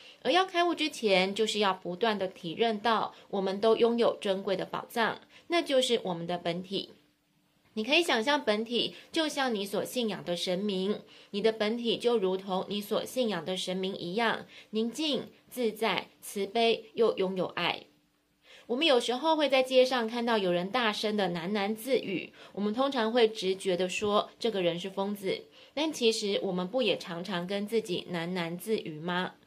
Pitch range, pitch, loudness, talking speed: 185-235 Hz, 210 Hz, -30 LUFS, 260 characters per minute